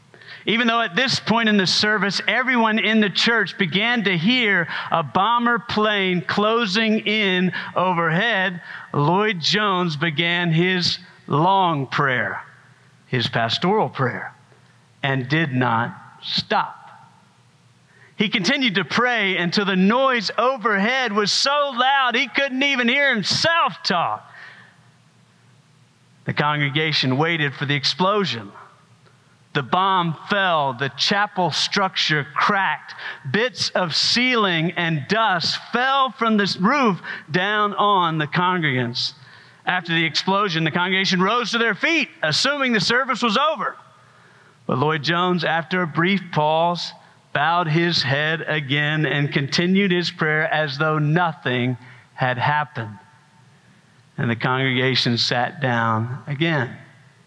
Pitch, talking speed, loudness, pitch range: 180 Hz, 125 wpm, -19 LUFS, 150-215 Hz